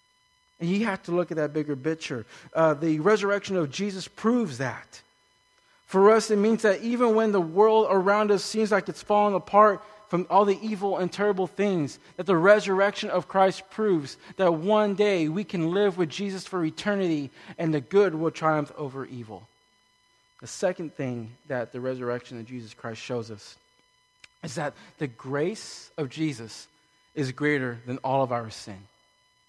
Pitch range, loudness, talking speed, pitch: 135-205 Hz, -25 LUFS, 175 wpm, 175 Hz